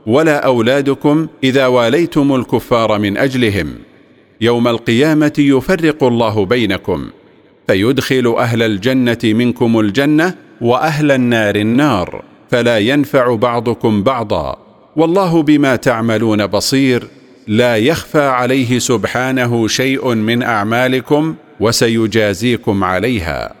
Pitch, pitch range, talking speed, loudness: 125 Hz, 115-135 Hz, 95 wpm, -13 LUFS